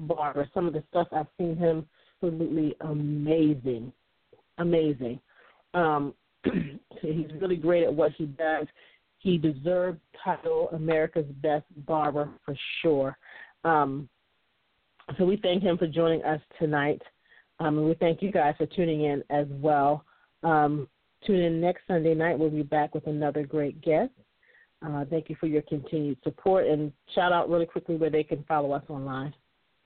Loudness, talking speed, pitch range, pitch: -28 LUFS, 155 wpm, 145-170 Hz, 155 Hz